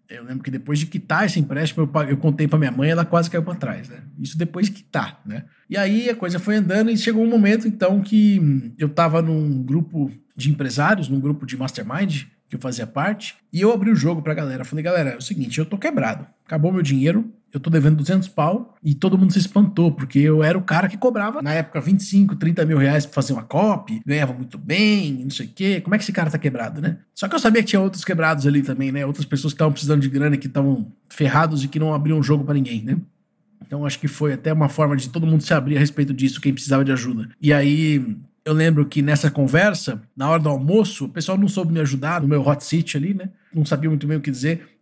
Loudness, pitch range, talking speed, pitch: -20 LUFS, 140-190 Hz, 255 wpm, 155 Hz